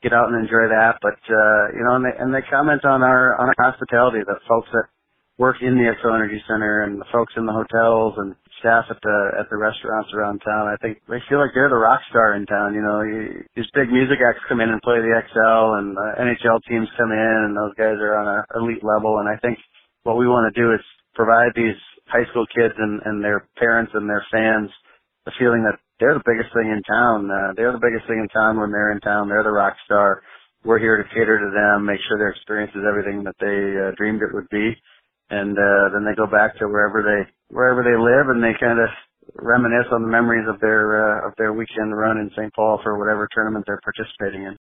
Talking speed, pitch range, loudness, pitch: 245 wpm, 105-115 Hz, -18 LUFS, 110 Hz